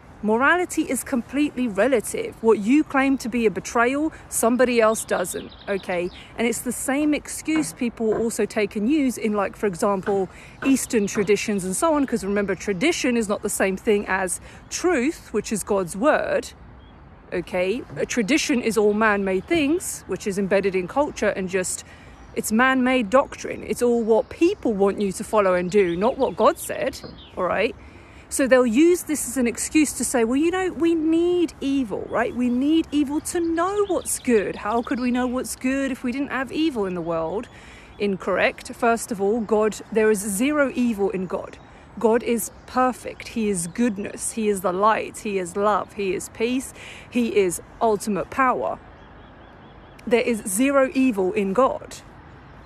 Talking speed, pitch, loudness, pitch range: 180 wpm, 235 Hz, -22 LUFS, 205-270 Hz